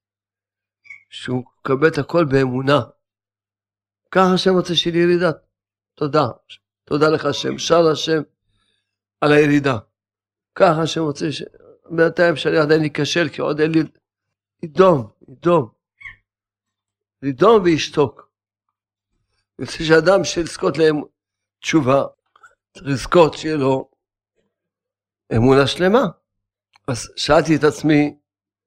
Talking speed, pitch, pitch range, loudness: 105 wpm, 145 Hz, 100-160 Hz, -17 LUFS